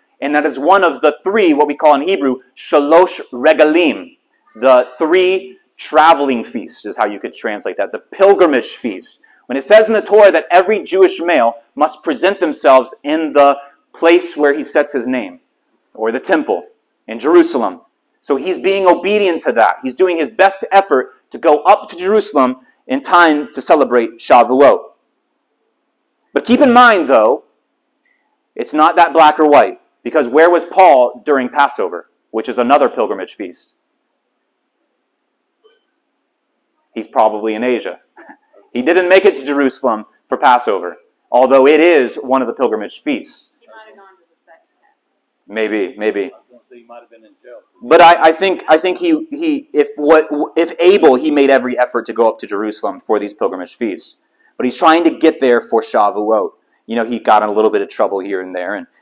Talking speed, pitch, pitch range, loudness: 170 wpm, 160 Hz, 135-205 Hz, -12 LUFS